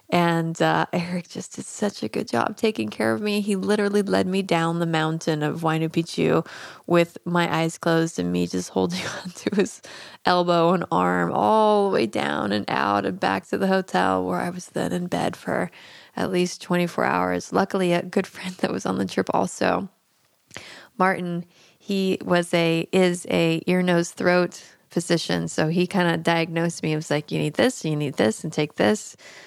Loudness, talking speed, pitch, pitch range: -23 LUFS, 195 wpm, 170 Hz, 145-180 Hz